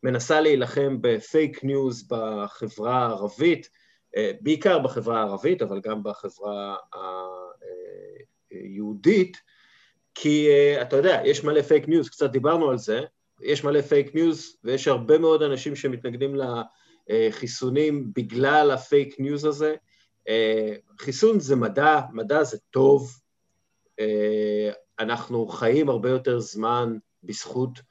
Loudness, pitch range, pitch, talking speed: -23 LUFS, 115-155 Hz, 135 Hz, 110 wpm